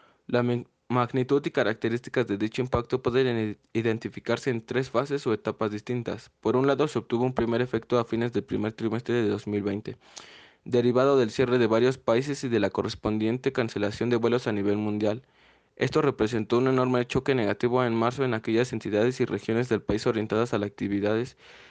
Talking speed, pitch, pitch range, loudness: 180 wpm, 120 Hz, 110-125 Hz, -27 LUFS